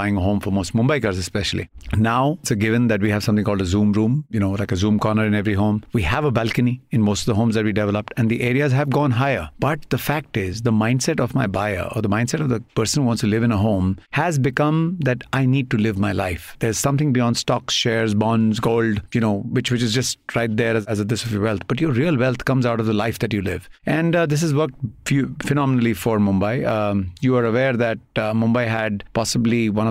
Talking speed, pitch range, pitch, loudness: 265 wpm, 105-130 Hz, 115 Hz, -20 LUFS